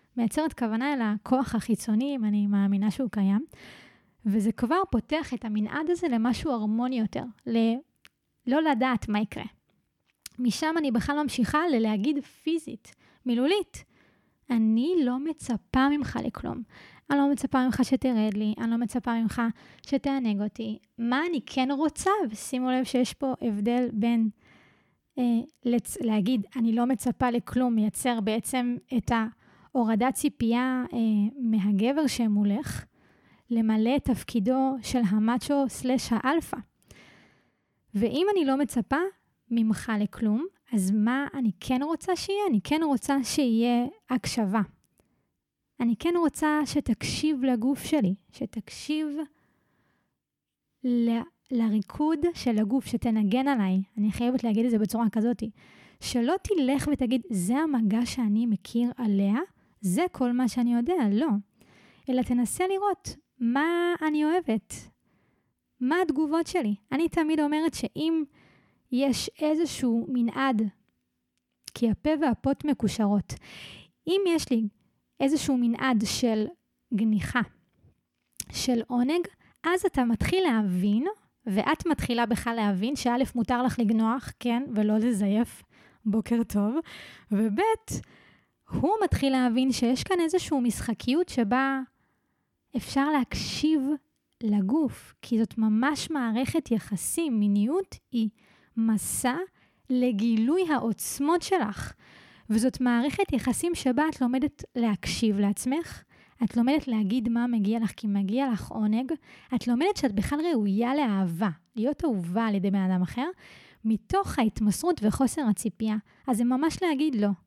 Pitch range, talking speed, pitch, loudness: 220-285 Hz, 125 wpm, 245 Hz, -27 LUFS